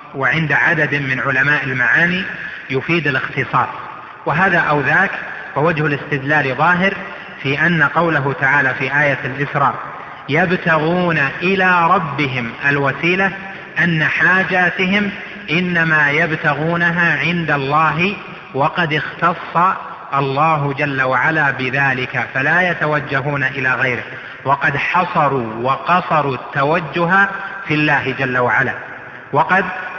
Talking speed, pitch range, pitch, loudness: 100 wpm, 135-175 Hz, 150 Hz, -15 LUFS